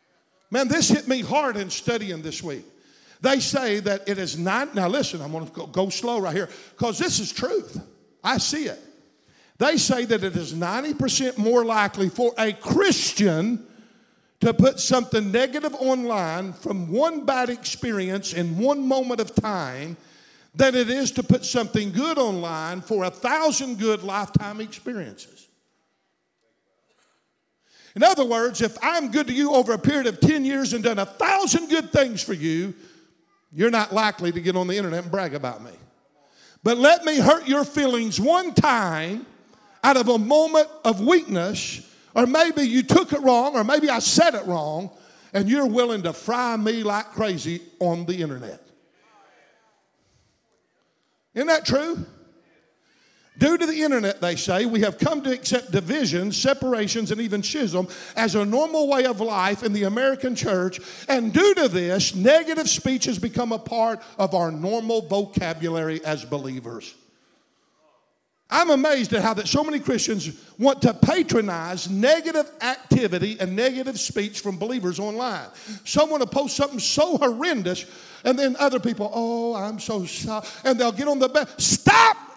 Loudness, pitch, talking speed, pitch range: -22 LUFS, 230 Hz, 165 wpm, 195-270 Hz